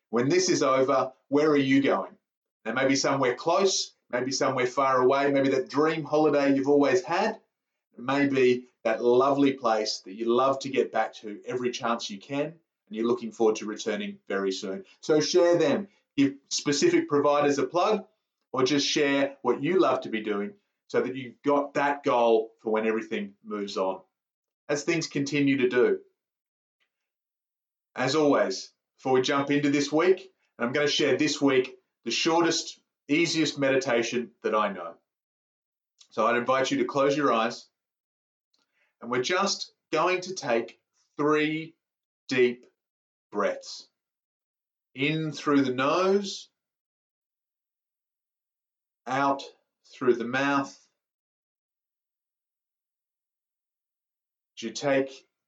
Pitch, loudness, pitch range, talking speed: 140 Hz, -26 LUFS, 120-160 Hz, 140 wpm